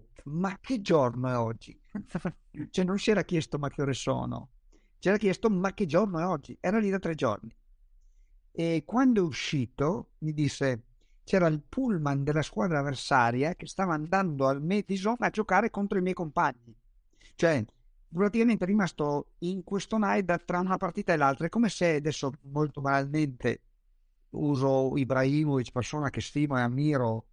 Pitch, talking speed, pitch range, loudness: 155 Hz, 165 wpm, 135-190 Hz, -29 LUFS